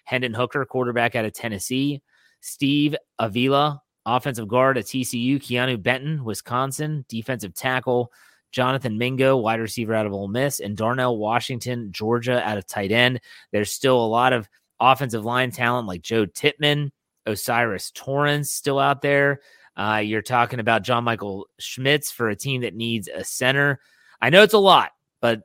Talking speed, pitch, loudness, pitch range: 165 wpm, 125 Hz, -22 LUFS, 115-135 Hz